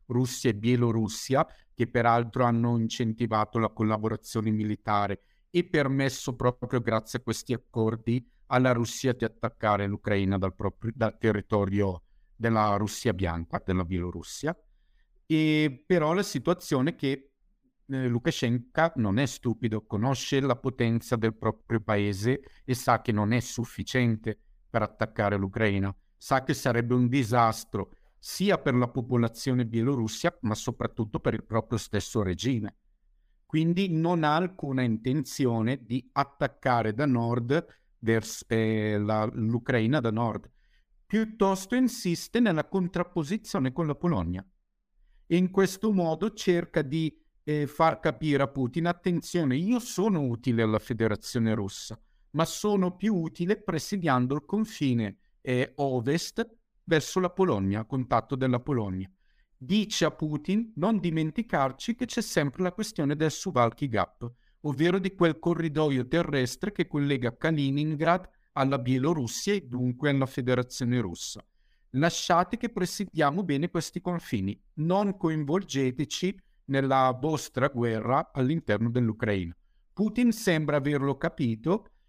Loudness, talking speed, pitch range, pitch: -28 LUFS, 125 wpm, 115-165 Hz, 130 Hz